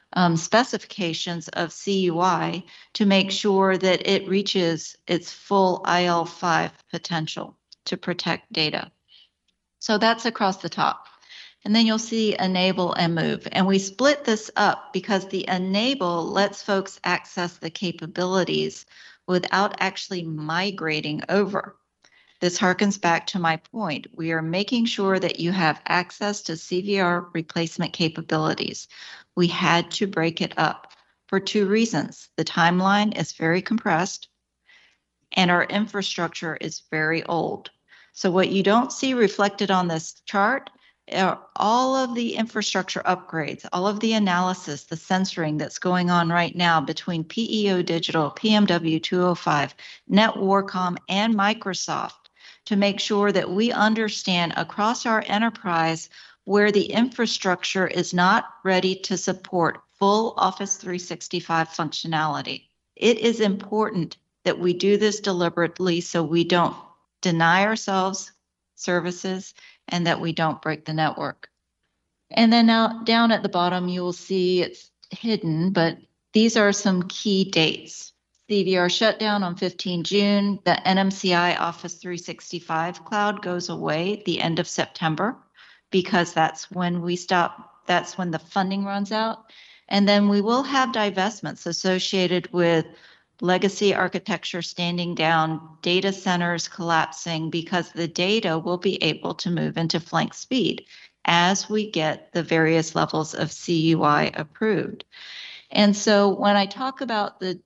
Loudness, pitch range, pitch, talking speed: -23 LUFS, 170-205 Hz, 185 Hz, 140 wpm